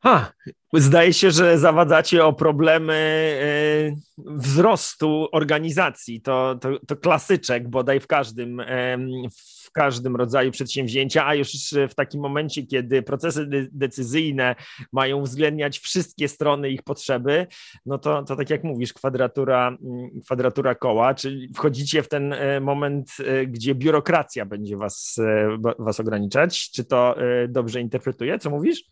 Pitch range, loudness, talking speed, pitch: 125-150 Hz, -21 LUFS, 125 wpm, 140 Hz